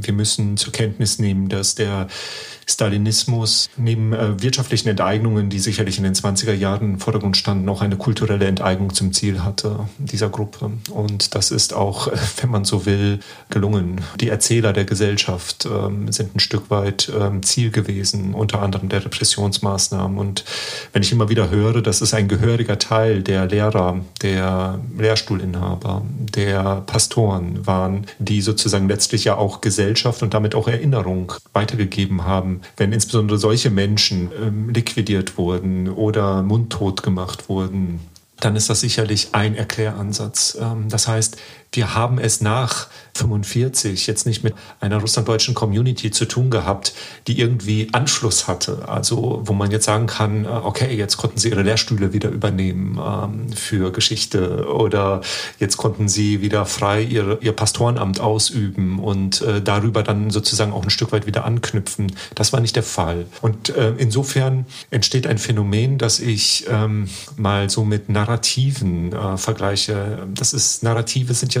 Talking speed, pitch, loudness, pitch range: 150 wpm, 105 Hz, -19 LUFS, 100-115 Hz